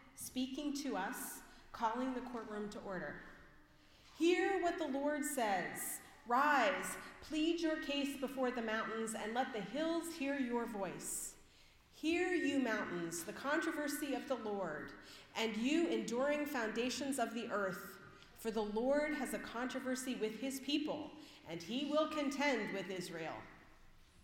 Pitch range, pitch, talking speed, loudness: 210-295 Hz, 250 Hz, 140 wpm, -39 LUFS